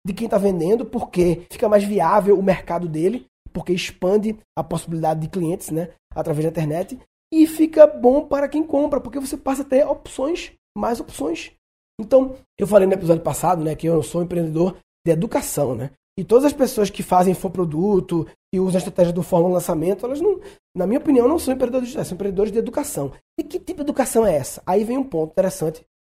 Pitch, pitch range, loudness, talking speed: 195 Hz, 170-260 Hz, -20 LUFS, 205 wpm